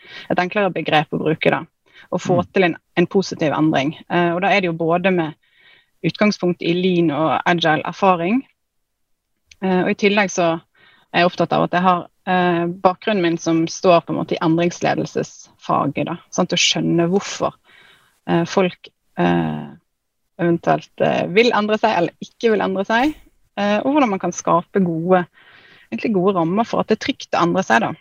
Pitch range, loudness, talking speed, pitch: 170-210 Hz, -18 LUFS, 180 wpm, 180 Hz